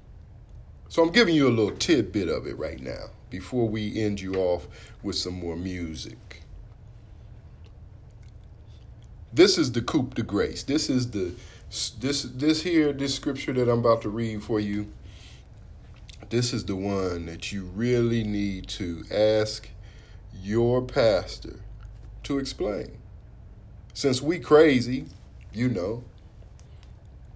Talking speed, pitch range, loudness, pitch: 130 wpm, 95-120 Hz, -25 LUFS, 110 Hz